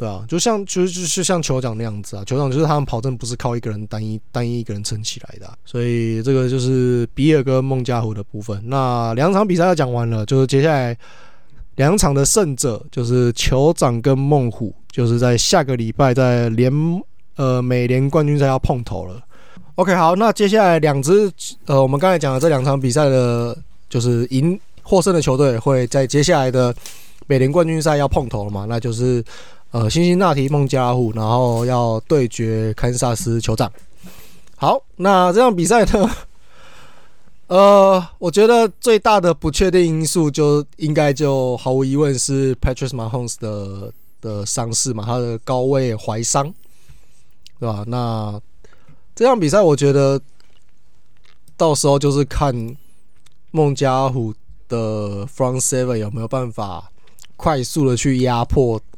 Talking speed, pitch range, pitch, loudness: 270 characters per minute, 120-155 Hz, 130 Hz, -17 LUFS